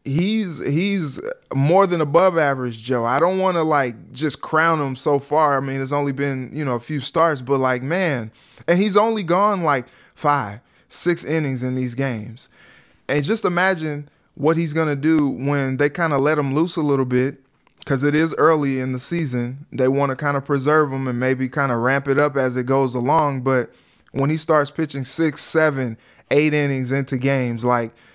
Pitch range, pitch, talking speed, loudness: 130-160 Hz, 140 Hz, 205 wpm, -20 LUFS